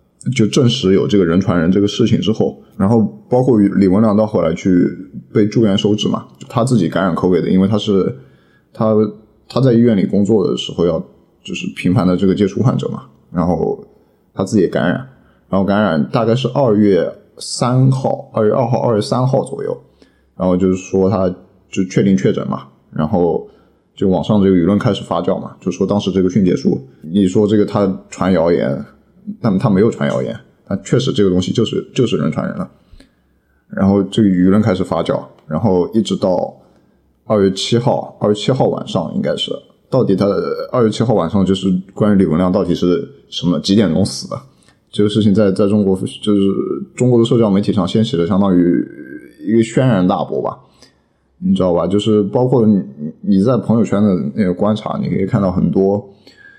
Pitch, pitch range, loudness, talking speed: 105 Hz, 95-115 Hz, -15 LUFS, 290 characters per minute